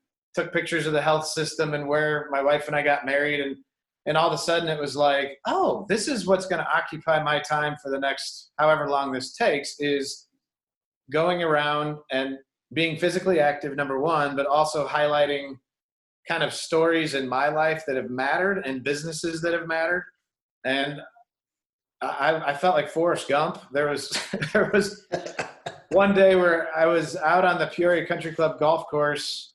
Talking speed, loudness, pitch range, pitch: 180 wpm, -24 LUFS, 145-170 Hz, 150 Hz